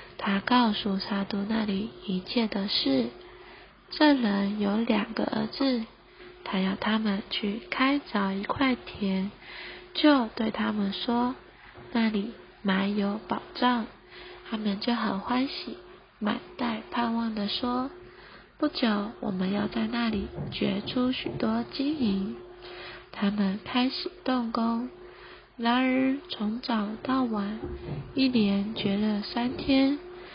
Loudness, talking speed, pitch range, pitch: -28 LUFS, 165 characters per minute, 205-260 Hz, 230 Hz